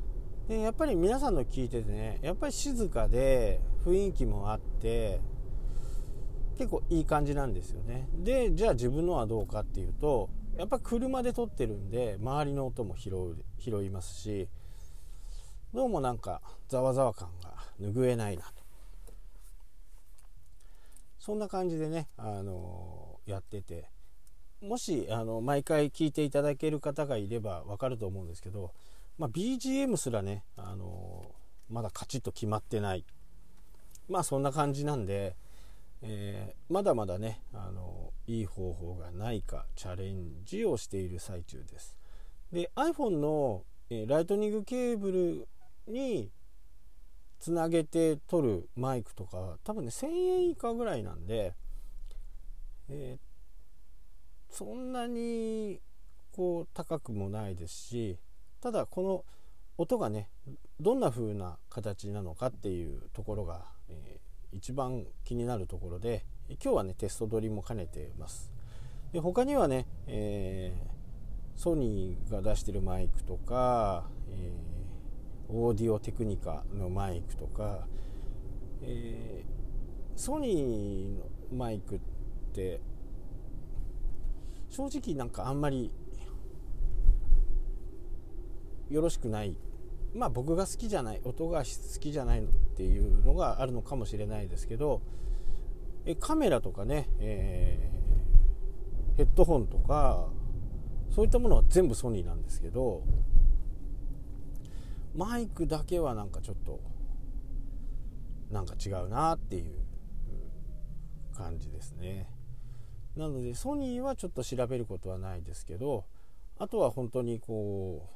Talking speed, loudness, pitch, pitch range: 255 characters per minute, -34 LUFS, 105 Hz, 90-135 Hz